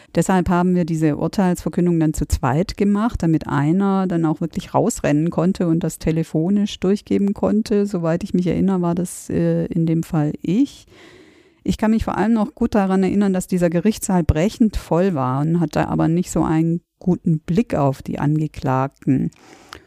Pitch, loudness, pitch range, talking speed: 175 Hz, -19 LUFS, 160-200 Hz, 170 wpm